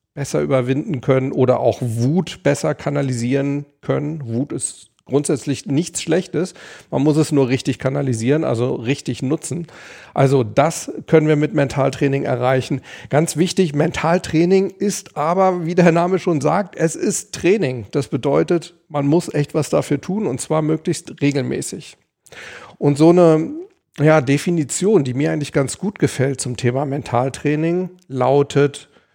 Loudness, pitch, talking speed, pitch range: -18 LUFS, 145 Hz, 145 wpm, 135-170 Hz